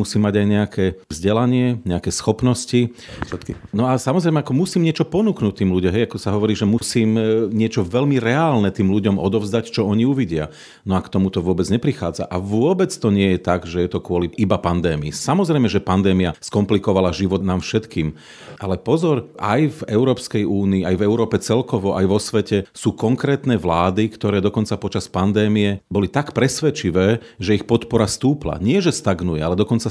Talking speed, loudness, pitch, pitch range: 180 wpm, -19 LUFS, 105 Hz, 95-120 Hz